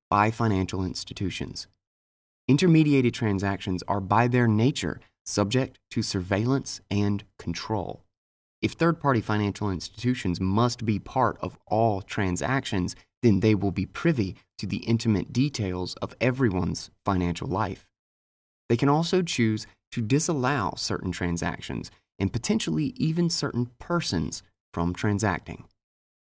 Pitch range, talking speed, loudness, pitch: 90-125 Hz, 120 wpm, -26 LUFS, 105 Hz